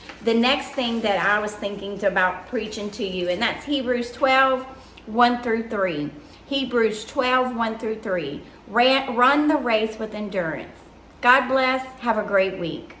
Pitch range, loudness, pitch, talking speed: 205-260 Hz, -22 LUFS, 230 Hz, 155 wpm